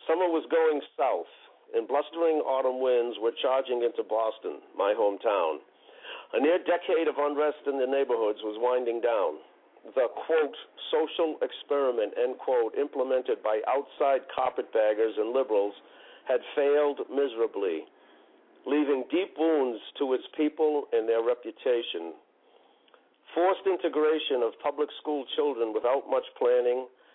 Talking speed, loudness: 130 wpm, -28 LUFS